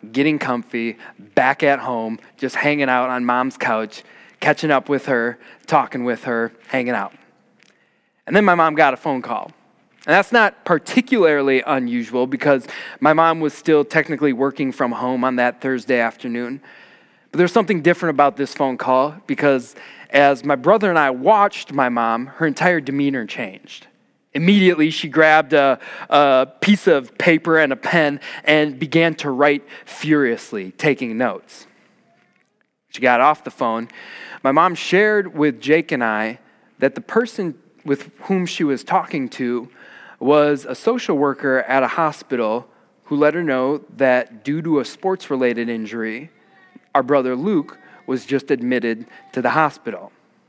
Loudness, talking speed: -18 LUFS, 160 wpm